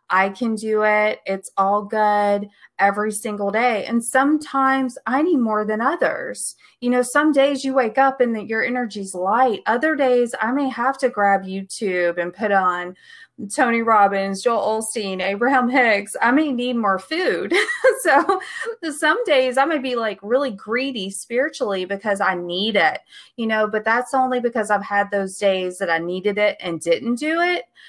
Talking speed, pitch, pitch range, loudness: 175 wpm, 230 Hz, 200-270 Hz, -20 LUFS